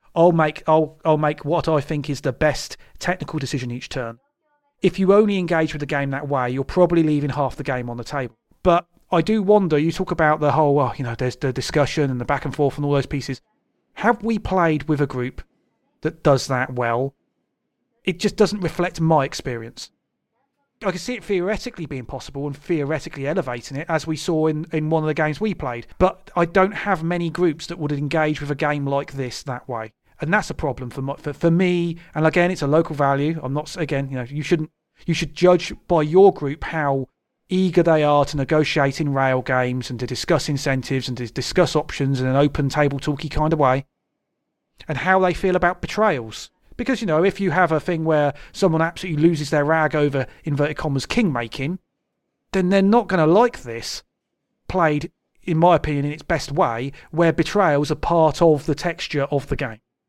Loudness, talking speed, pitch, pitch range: -21 LUFS, 215 wpm, 155 Hz, 140-175 Hz